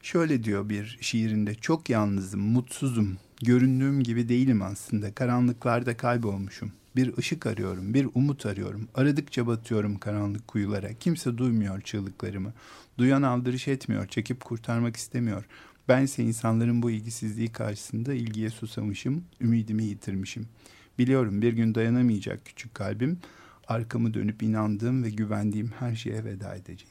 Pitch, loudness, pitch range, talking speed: 115 Hz, -28 LUFS, 105-125 Hz, 125 wpm